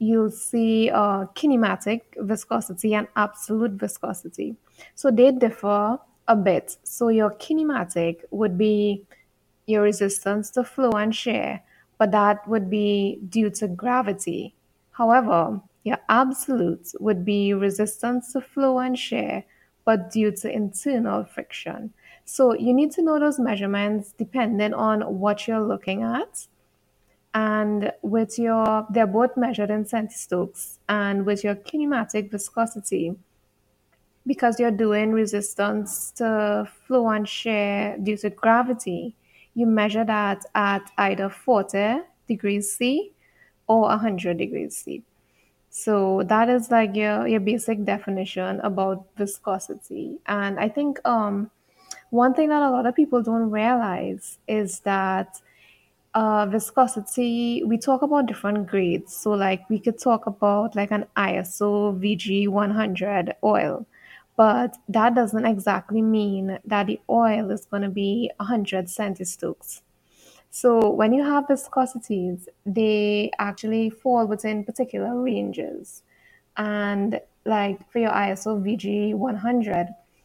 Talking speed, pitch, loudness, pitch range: 130 wpm, 215 Hz, -23 LUFS, 200-235 Hz